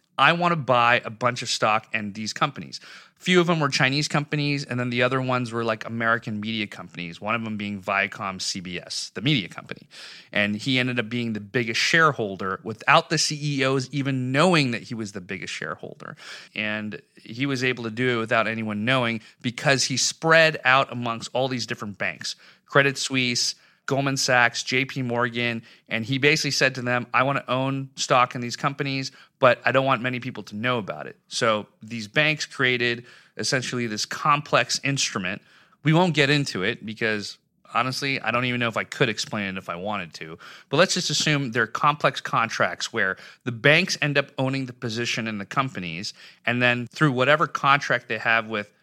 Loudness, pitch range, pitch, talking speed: -23 LUFS, 115-140 Hz, 125 Hz, 195 wpm